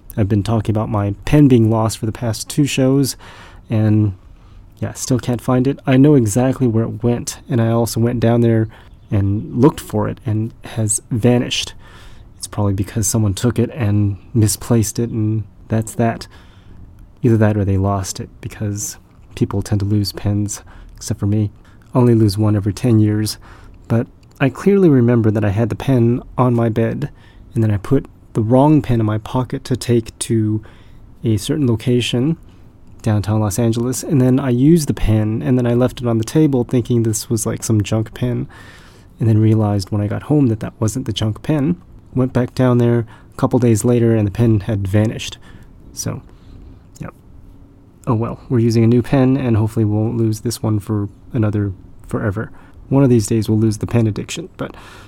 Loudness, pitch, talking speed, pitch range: -17 LUFS, 110 Hz, 195 wpm, 105-120 Hz